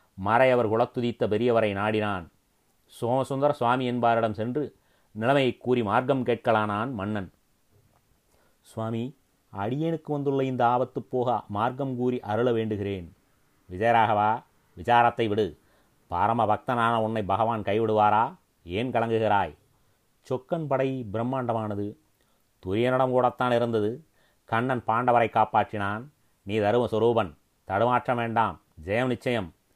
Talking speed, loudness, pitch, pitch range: 100 wpm, -26 LUFS, 115 Hz, 105-125 Hz